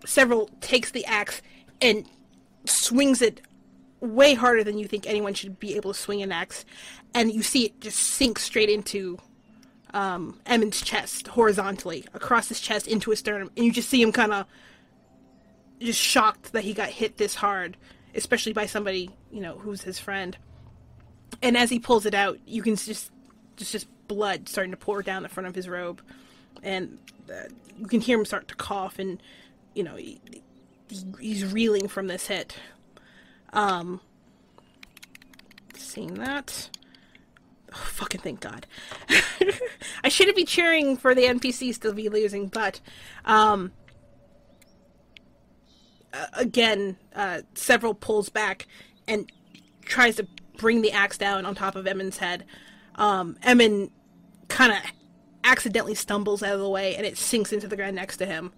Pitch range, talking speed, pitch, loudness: 195-235 Hz, 160 wpm, 210 Hz, -24 LUFS